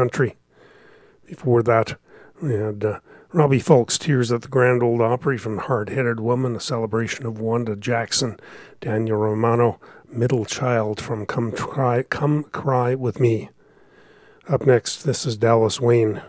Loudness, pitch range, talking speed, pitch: -21 LUFS, 115-130 Hz, 145 wpm, 120 Hz